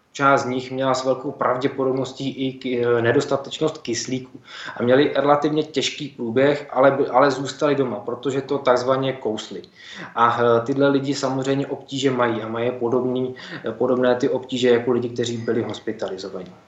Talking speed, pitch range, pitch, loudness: 145 wpm, 120-140 Hz, 130 Hz, -21 LUFS